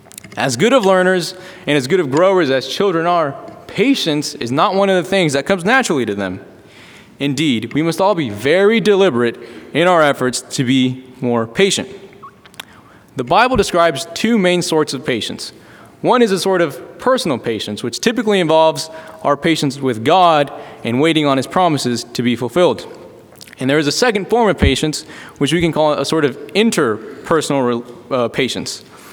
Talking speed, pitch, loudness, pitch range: 175 wpm, 160 Hz, -15 LUFS, 135-190 Hz